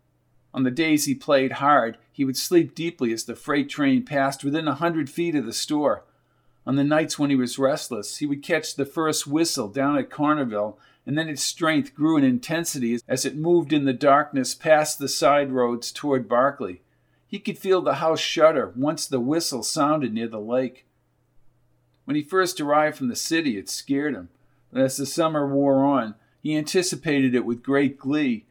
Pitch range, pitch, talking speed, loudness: 130-160 Hz, 140 Hz, 195 wpm, -23 LUFS